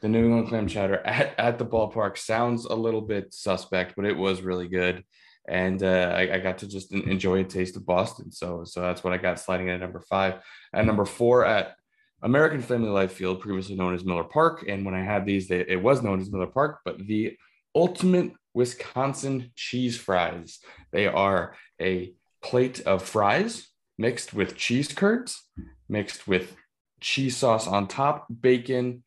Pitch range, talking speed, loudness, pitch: 90-120 Hz, 185 wpm, -26 LUFS, 100 Hz